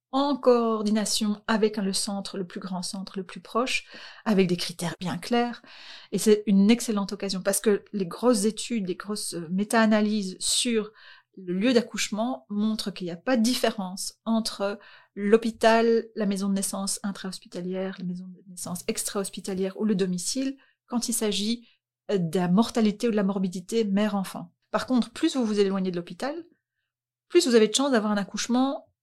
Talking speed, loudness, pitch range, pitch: 170 wpm, -26 LUFS, 195-230 Hz, 210 Hz